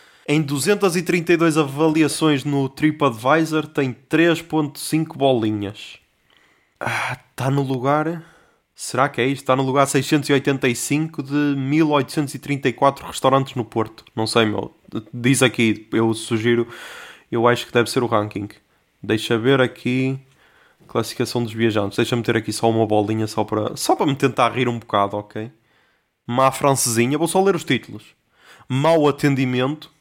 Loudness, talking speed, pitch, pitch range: -20 LUFS, 140 wpm, 130 Hz, 115-145 Hz